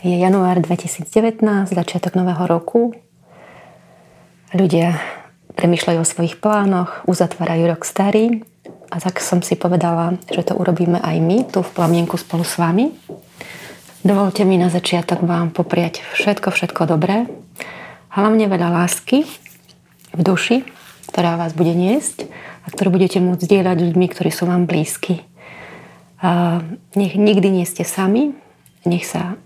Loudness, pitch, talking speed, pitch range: -17 LUFS, 180 Hz, 130 wpm, 170-195 Hz